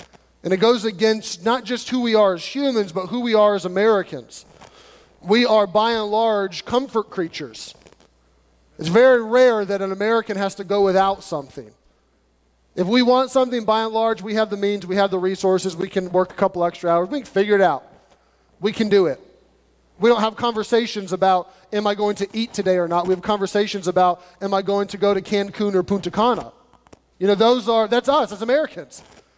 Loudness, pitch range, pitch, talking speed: -20 LUFS, 185-225 Hz, 205 Hz, 205 wpm